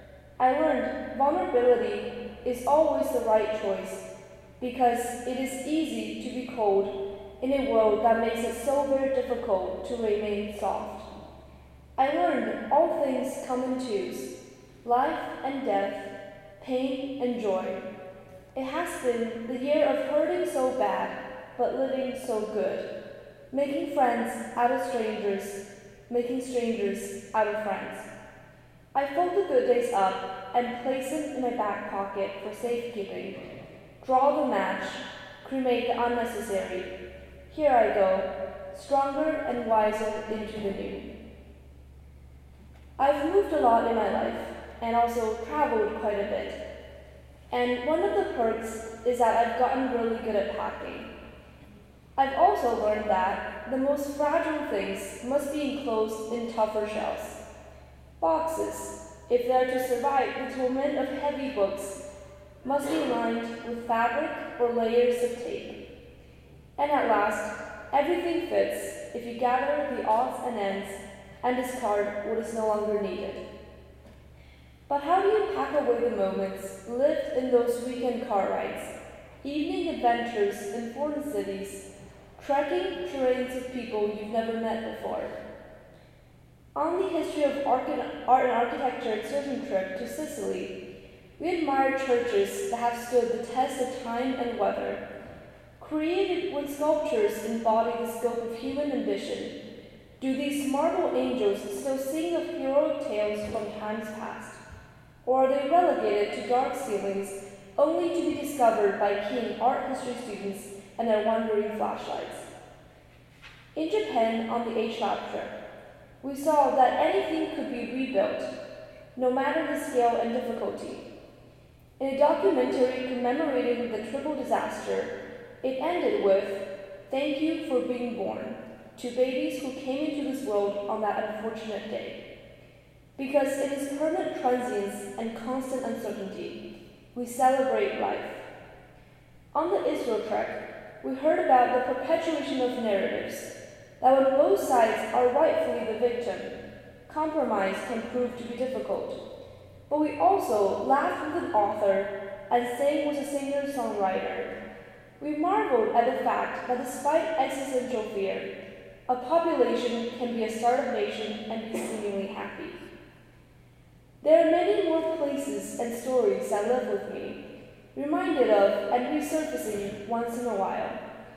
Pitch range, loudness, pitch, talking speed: 210-280 Hz, -28 LUFS, 245 Hz, 140 wpm